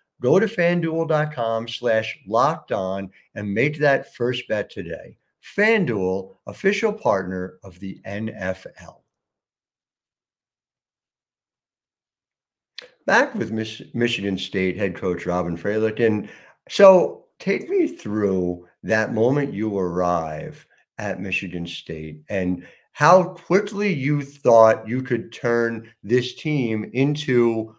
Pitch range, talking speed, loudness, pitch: 95-145 Hz, 105 wpm, -22 LUFS, 110 Hz